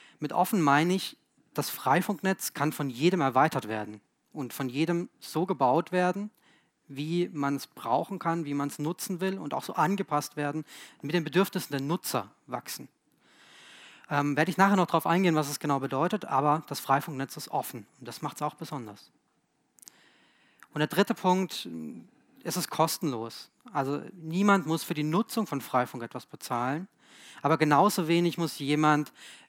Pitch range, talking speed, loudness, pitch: 140-185 Hz, 170 wpm, -29 LUFS, 160 Hz